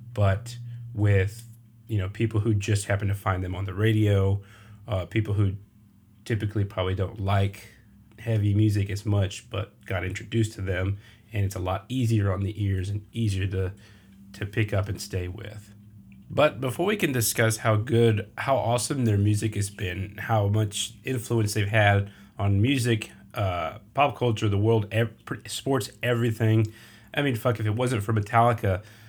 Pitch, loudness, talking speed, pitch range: 105 Hz, -26 LUFS, 170 wpm, 100-115 Hz